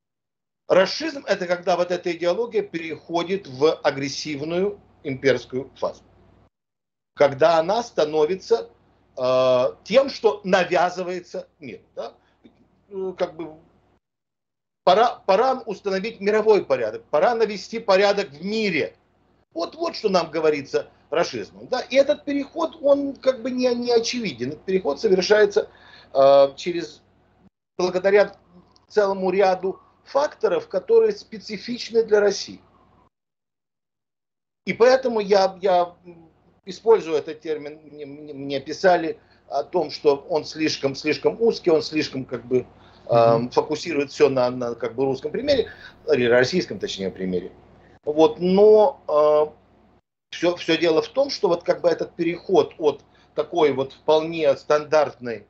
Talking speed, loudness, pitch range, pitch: 120 wpm, -21 LUFS, 145-220 Hz, 180 Hz